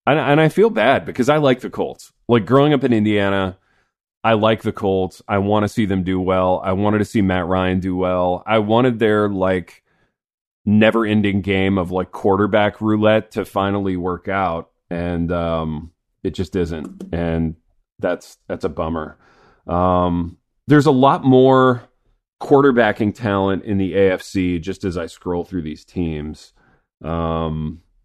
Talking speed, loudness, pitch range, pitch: 165 wpm, -18 LUFS, 90-110 Hz, 95 Hz